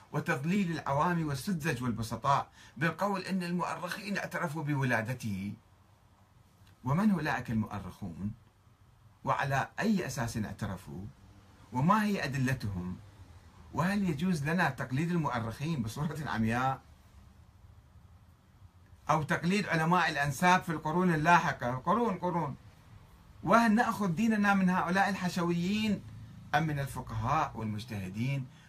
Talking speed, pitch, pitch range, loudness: 95 wpm, 140 Hz, 105-175 Hz, -31 LUFS